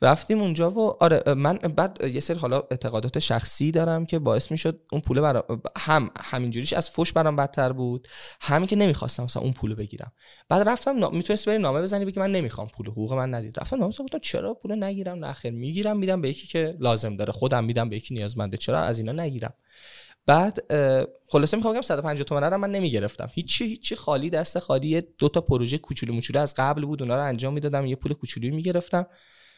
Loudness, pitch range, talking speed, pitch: -25 LUFS, 125-180 Hz, 205 wpm, 150 Hz